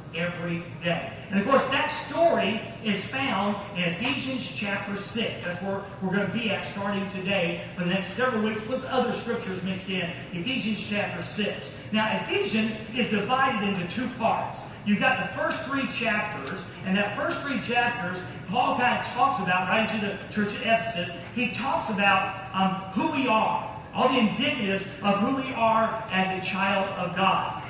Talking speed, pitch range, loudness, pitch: 180 wpm, 190-240 Hz, -26 LUFS, 205 Hz